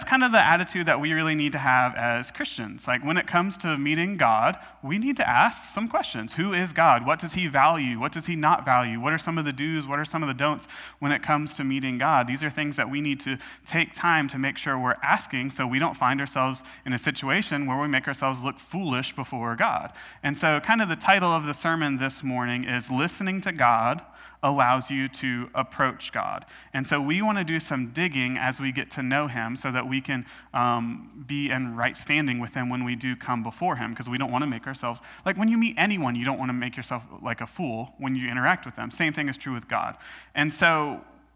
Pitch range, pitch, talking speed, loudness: 125-160 Hz, 140 Hz, 250 wpm, -25 LUFS